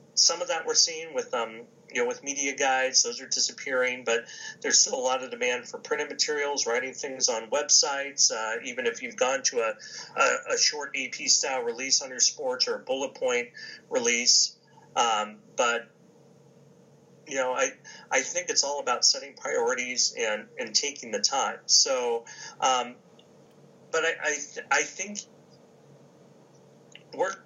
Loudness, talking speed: -25 LUFS, 160 wpm